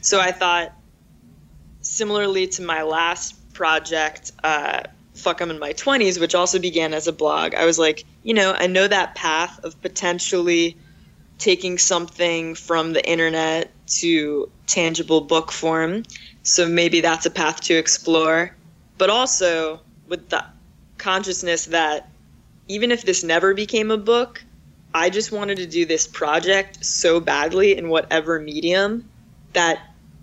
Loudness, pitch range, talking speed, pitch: -20 LUFS, 160-190 Hz, 145 wpm, 170 Hz